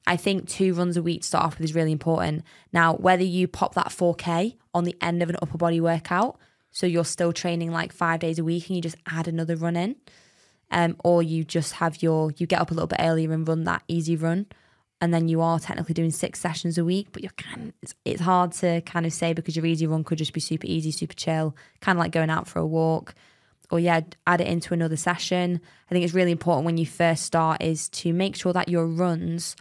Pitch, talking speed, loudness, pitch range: 170 Hz, 250 wpm, -25 LUFS, 165-175 Hz